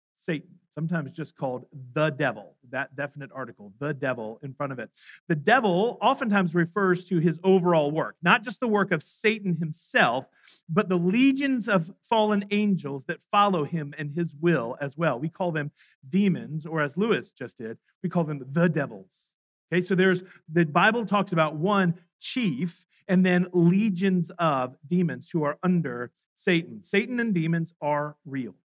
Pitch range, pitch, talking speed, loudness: 155-195 Hz, 175 Hz, 170 wpm, -26 LUFS